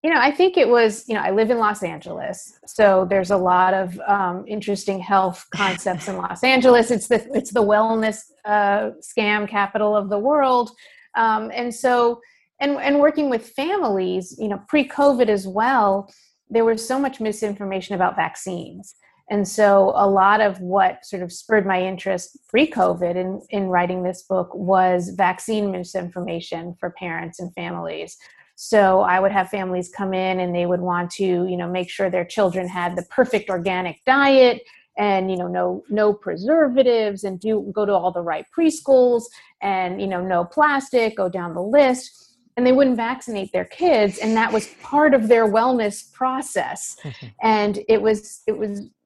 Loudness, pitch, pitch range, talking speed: -20 LUFS, 205 Hz, 185-235 Hz, 180 wpm